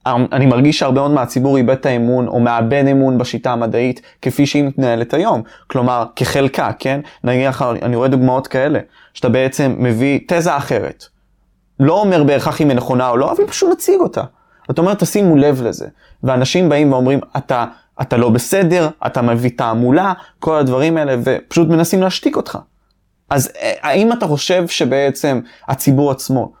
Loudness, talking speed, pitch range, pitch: -15 LUFS, 160 wpm, 125-150 Hz, 135 Hz